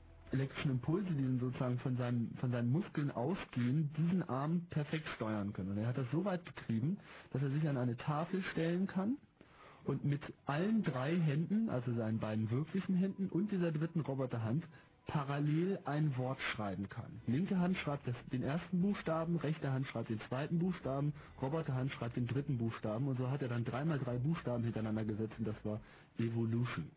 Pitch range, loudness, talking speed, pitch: 120-165 Hz, -38 LUFS, 175 wpm, 140 Hz